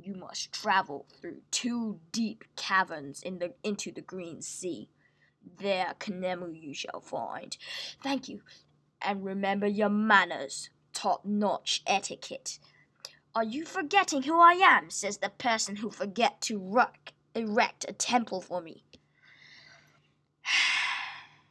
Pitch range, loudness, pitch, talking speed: 185-245 Hz, -29 LUFS, 205 Hz, 125 wpm